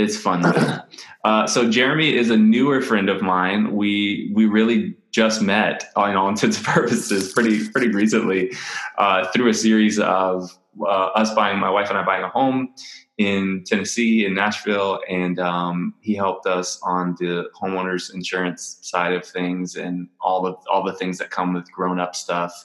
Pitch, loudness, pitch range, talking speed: 95 Hz, -20 LUFS, 90-110 Hz, 185 wpm